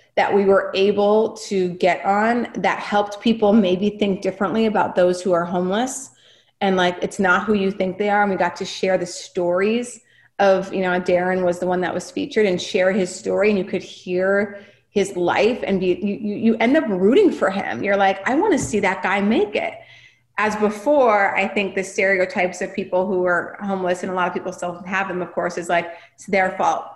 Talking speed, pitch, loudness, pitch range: 220 wpm, 195 Hz, -20 LUFS, 180-205 Hz